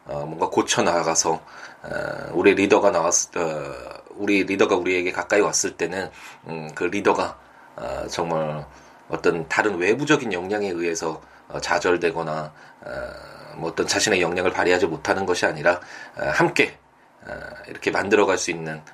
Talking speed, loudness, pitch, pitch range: 310 characters per minute, -22 LUFS, 80 Hz, 80-90 Hz